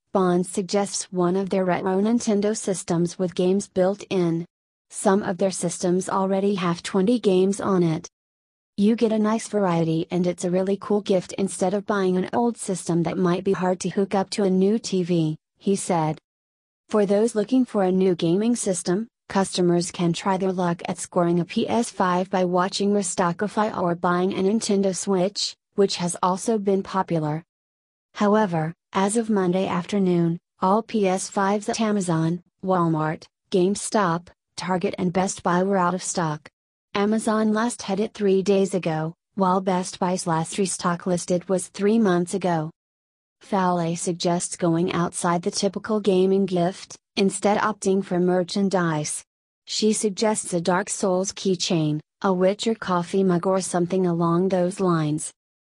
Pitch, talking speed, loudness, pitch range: 185 Hz, 155 wpm, -23 LUFS, 175-200 Hz